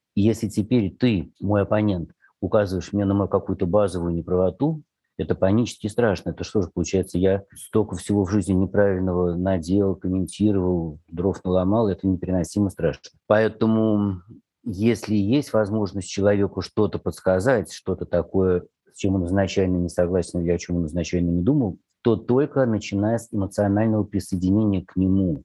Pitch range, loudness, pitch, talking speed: 90-105 Hz, -23 LUFS, 95 Hz, 145 wpm